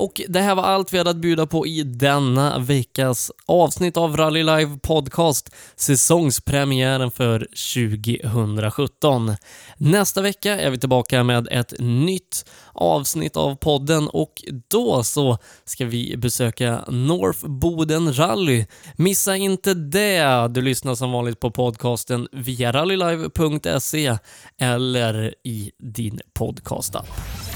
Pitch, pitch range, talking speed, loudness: 135 Hz, 120-160 Hz, 120 wpm, -20 LUFS